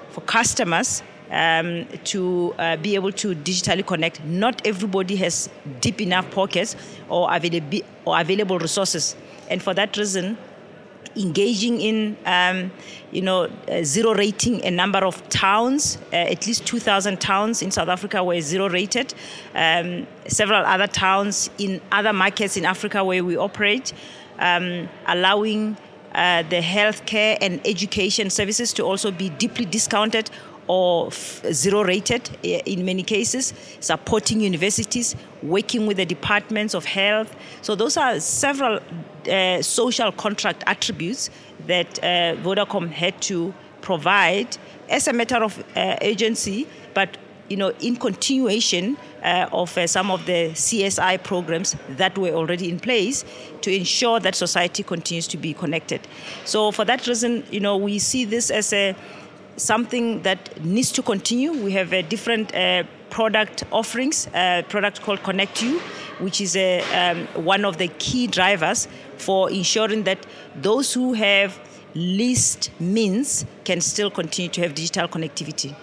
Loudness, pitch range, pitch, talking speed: -21 LUFS, 180-215 Hz, 195 Hz, 150 wpm